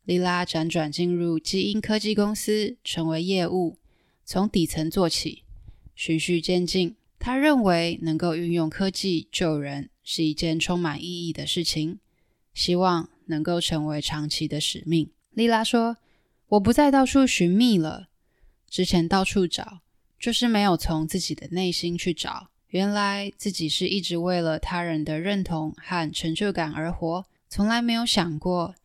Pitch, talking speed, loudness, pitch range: 175 Hz, 230 characters per minute, -24 LUFS, 160-195 Hz